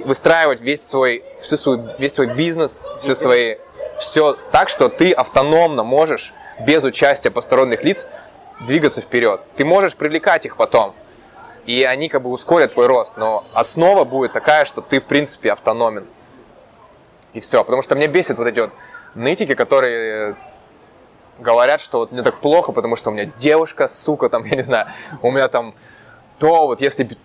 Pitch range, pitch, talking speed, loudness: 125-160 Hz, 145 Hz, 165 wpm, -16 LUFS